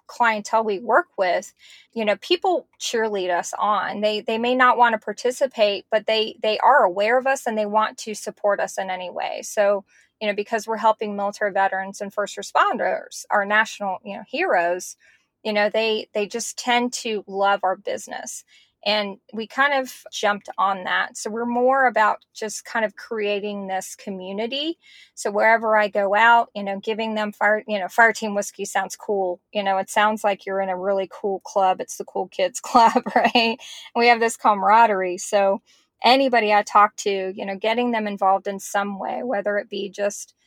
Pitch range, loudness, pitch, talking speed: 200-230 Hz, -21 LUFS, 210 Hz, 195 wpm